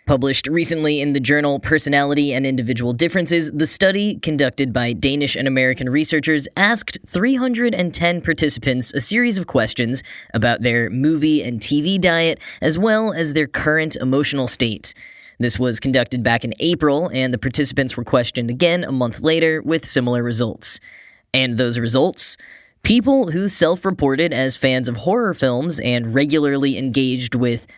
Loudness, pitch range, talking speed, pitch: -17 LUFS, 125-165 Hz, 155 wpm, 140 Hz